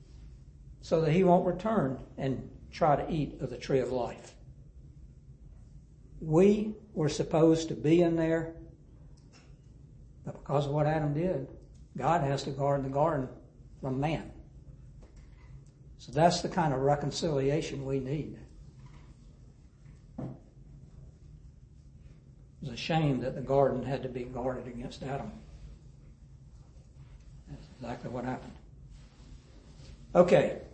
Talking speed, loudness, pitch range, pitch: 115 wpm, -30 LUFS, 130-160 Hz, 140 Hz